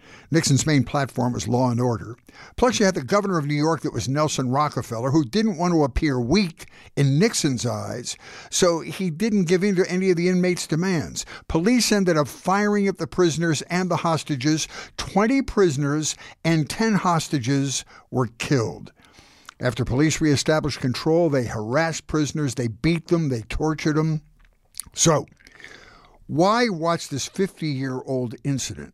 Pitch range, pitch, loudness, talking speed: 135-180 Hz, 155 Hz, -22 LUFS, 160 wpm